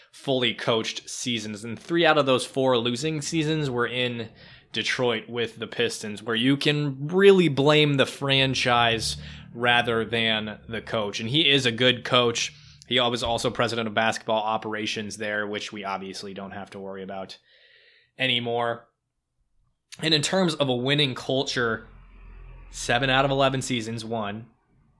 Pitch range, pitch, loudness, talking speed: 110-135 Hz, 120 Hz, -24 LUFS, 155 wpm